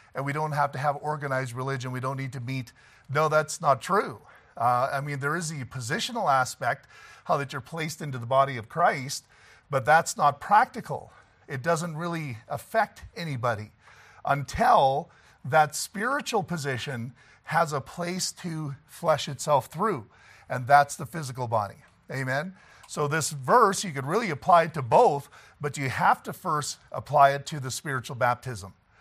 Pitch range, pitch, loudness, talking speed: 130-160 Hz, 145 Hz, -26 LUFS, 170 wpm